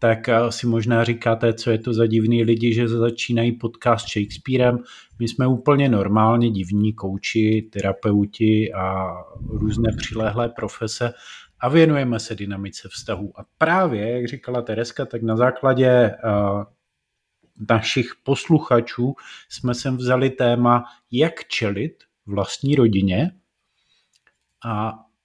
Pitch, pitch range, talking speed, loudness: 115 Hz, 110-125 Hz, 115 wpm, -21 LUFS